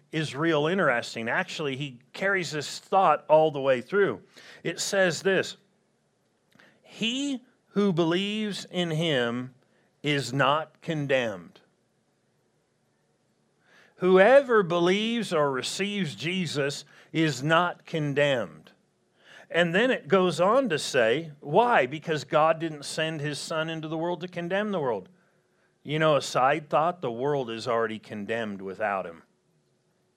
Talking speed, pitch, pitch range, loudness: 125 wpm, 160 Hz, 145-190 Hz, -26 LUFS